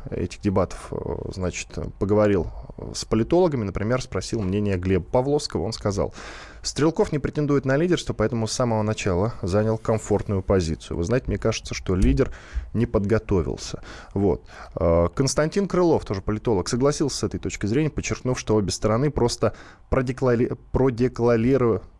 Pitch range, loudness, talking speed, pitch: 100-130 Hz, -24 LUFS, 135 wpm, 110 Hz